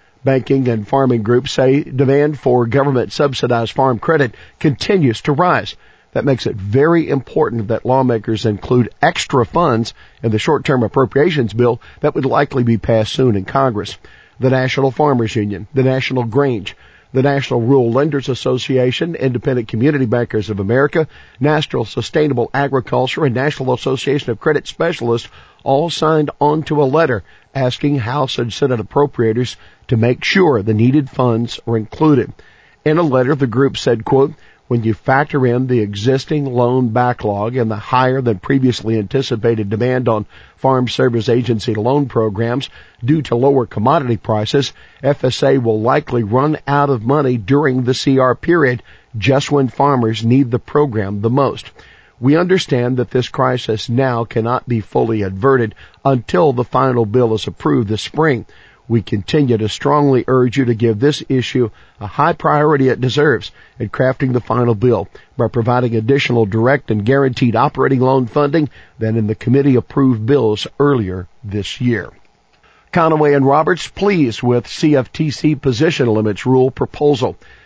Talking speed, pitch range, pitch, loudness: 155 wpm, 115-140 Hz, 130 Hz, -15 LUFS